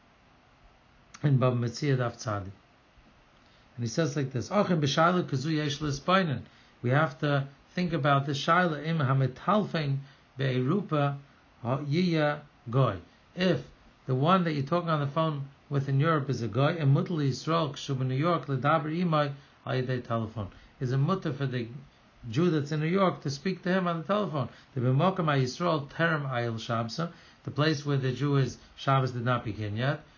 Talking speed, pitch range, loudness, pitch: 180 wpm, 130-160 Hz, -29 LUFS, 140 Hz